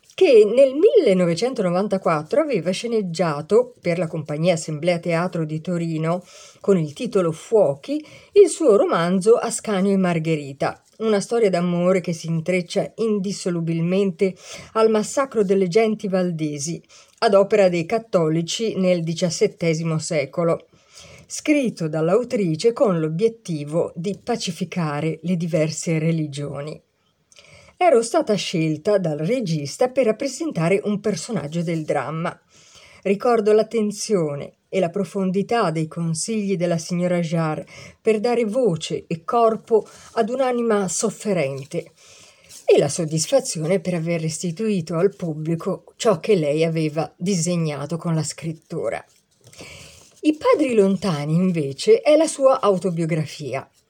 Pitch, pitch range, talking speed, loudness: 185 Hz, 165-215 Hz, 115 wpm, -21 LUFS